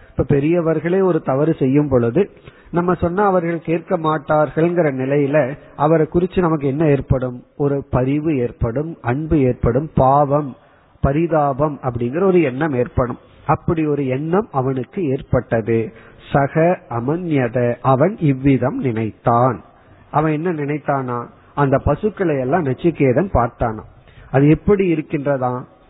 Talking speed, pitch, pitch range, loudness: 110 wpm, 145 Hz, 125-160 Hz, -18 LUFS